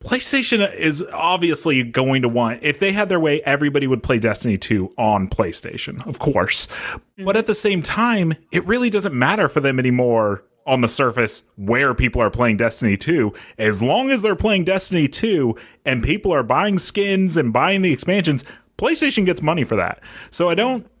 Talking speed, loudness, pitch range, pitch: 185 wpm, -18 LUFS, 125-200 Hz, 155 Hz